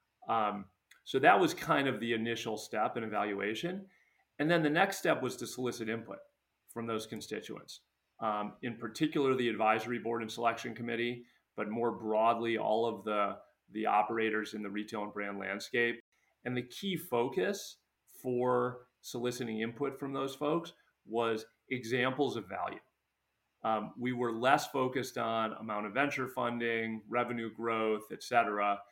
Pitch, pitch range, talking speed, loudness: 115 Hz, 110-130 Hz, 155 wpm, -34 LUFS